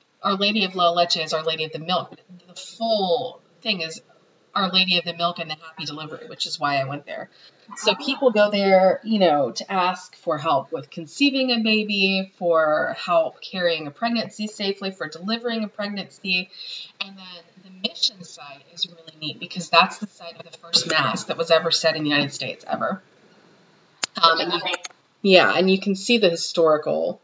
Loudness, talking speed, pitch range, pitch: -21 LUFS, 195 wpm, 165-200 Hz, 180 Hz